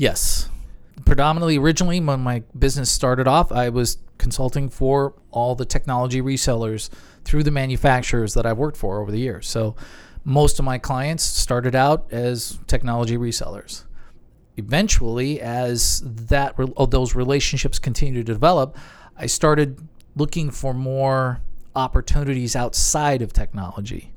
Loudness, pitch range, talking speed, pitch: -21 LUFS, 120-140 Hz, 130 wpm, 130 Hz